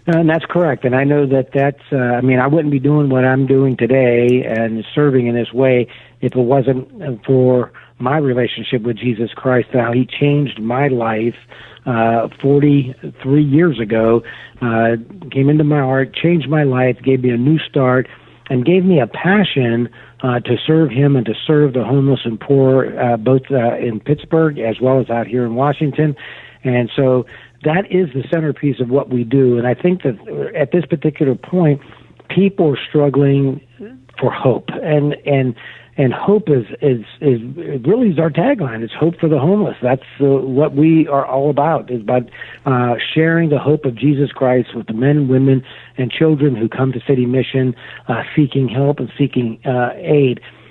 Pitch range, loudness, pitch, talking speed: 125-145 Hz, -15 LUFS, 135 Hz, 190 wpm